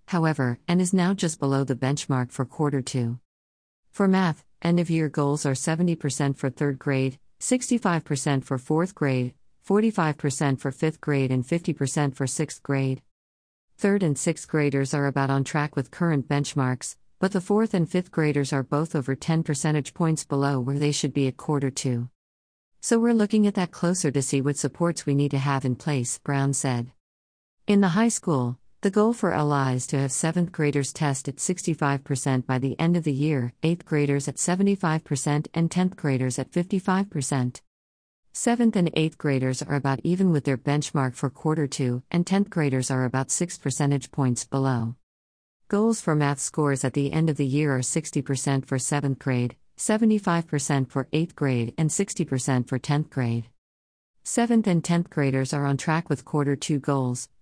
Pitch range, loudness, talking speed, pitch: 135-165 Hz, -25 LUFS, 180 wpm, 145 Hz